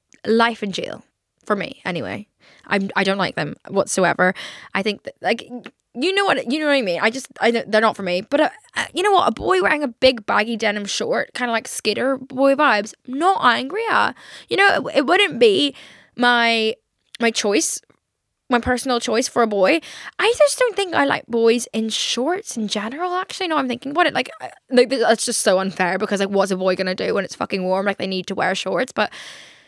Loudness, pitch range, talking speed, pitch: -19 LUFS, 210-285 Hz, 220 wpm, 240 Hz